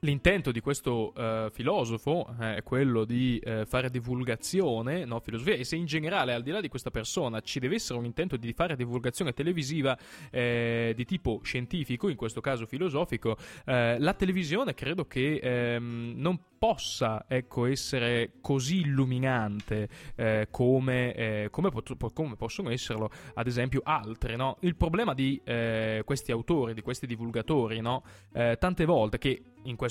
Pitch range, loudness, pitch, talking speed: 115-150 Hz, -30 LUFS, 125 Hz, 160 wpm